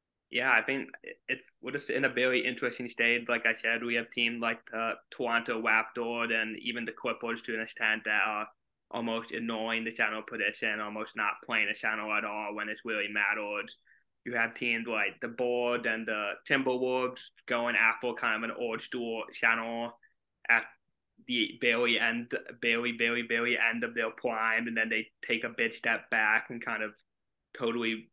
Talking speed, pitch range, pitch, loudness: 185 wpm, 110-120 Hz, 115 Hz, -30 LUFS